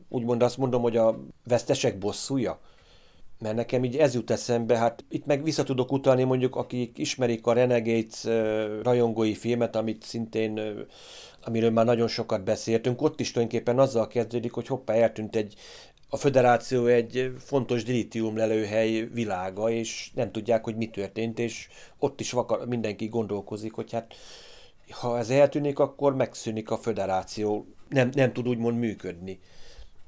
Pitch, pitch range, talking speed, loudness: 115 Hz, 110-125 Hz, 150 wpm, -27 LUFS